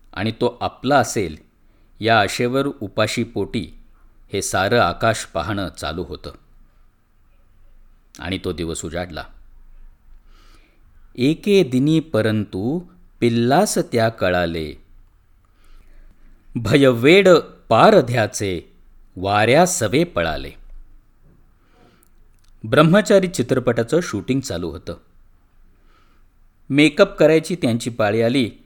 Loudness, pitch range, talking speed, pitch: -18 LUFS, 90-125 Hz, 85 wpm, 105 Hz